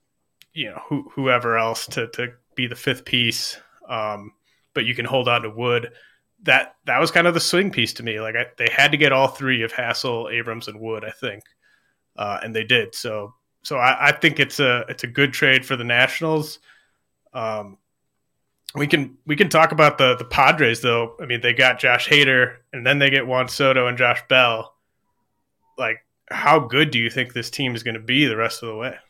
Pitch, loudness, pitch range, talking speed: 125 Hz, -19 LUFS, 115-140 Hz, 215 wpm